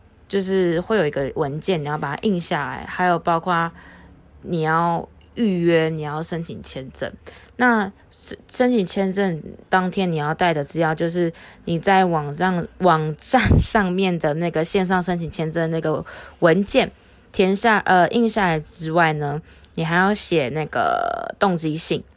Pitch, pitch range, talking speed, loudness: 175 Hz, 160-195 Hz, 225 characters per minute, -20 LUFS